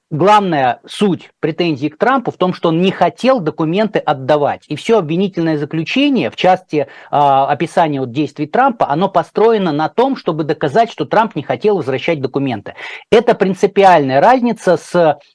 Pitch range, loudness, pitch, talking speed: 150-210 Hz, -14 LUFS, 170 Hz, 155 wpm